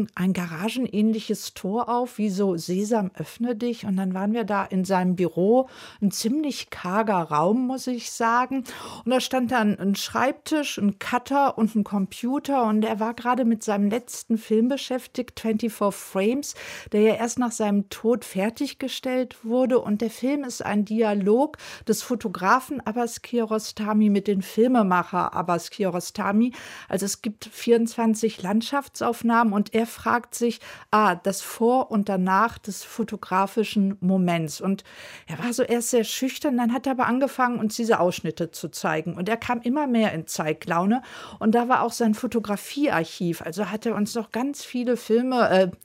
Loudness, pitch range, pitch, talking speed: -24 LUFS, 200-245 Hz, 225 Hz, 165 wpm